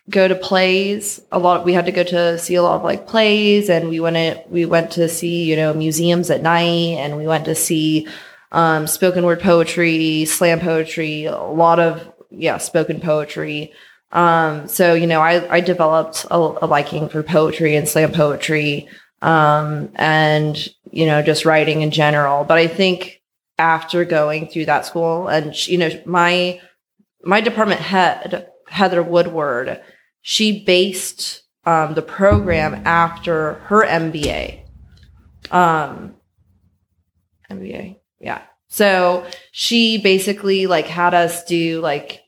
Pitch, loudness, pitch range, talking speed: 165 Hz, -16 LUFS, 155-180 Hz, 150 wpm